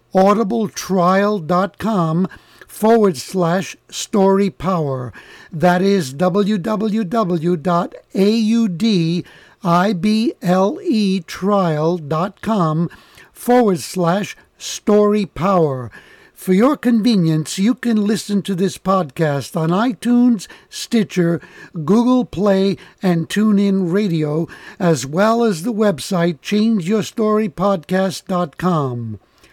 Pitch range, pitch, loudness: 170-215 Hz, 195 Hz, -17 LUFS